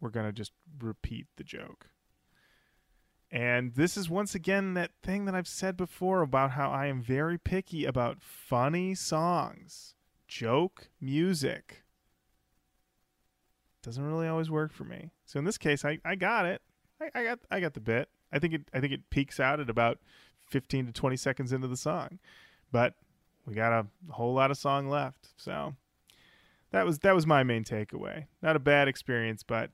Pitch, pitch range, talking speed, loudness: 145 Hz, 125-175 Hz, 180 wpm, -31 LUFS